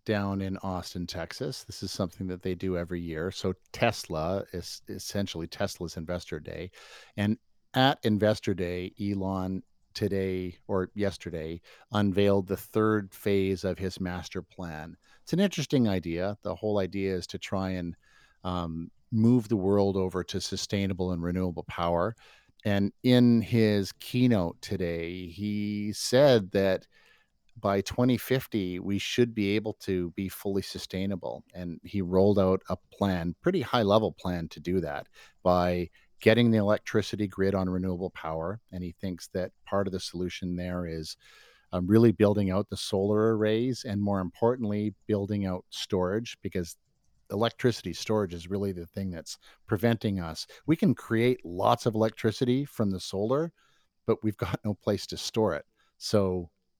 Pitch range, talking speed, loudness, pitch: 90-110 Hz, 155 wpm, -29 LUFS, 100 Hz